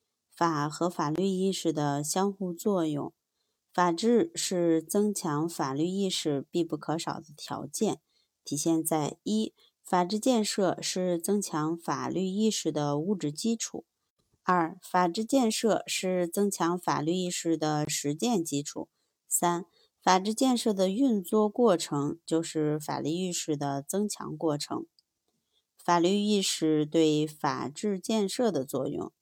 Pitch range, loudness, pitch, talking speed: 155-200 Hz, -29 LUFS, 175 Hz, 200 characters per minute